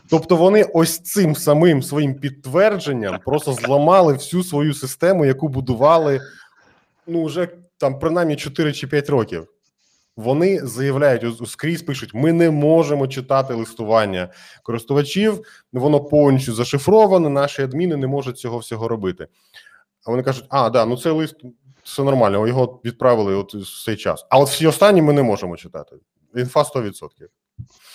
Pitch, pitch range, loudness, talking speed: 140 Hz, 125-160 Hz, -18 LUFS, 145 wpm